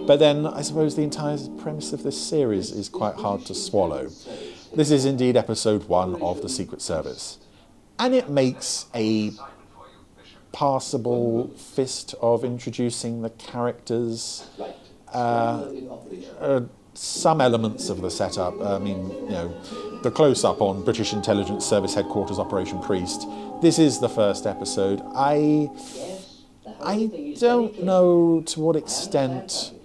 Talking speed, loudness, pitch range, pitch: 135 wpm, -23 LUFS, 115-150 Hz, 130 Hz